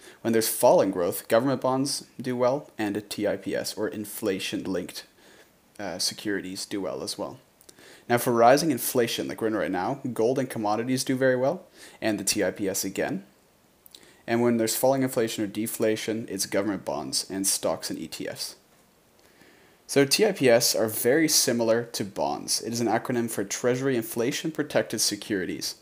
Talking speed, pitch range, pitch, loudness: 160 wpm, 110-130 Hz, 120 Hz, -26 LUFS